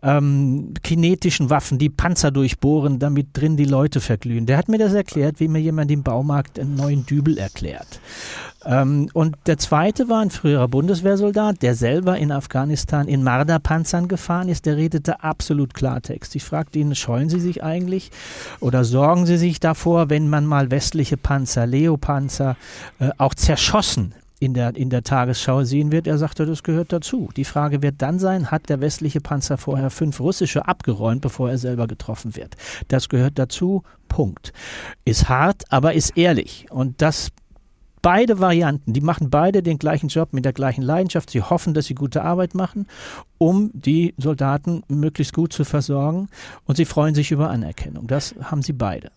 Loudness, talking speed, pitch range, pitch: -20 LUFS, 175 wpm, 135-165 Hz, 150 Hz